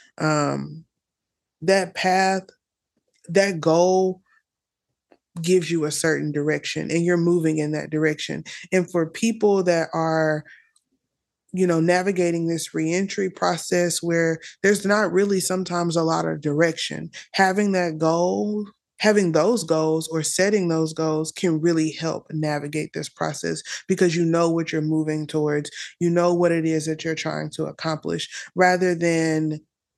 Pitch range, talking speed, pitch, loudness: 155-185 Hz, 145 wpm, 170 Hz, -22 LUFS